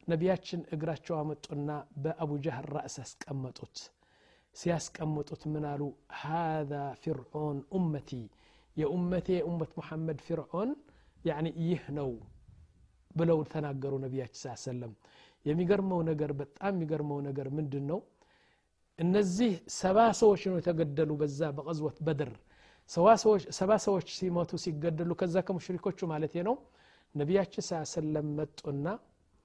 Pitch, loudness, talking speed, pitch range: 160 Hz, -33 LUFS, 115 wpm, 145-180 Hz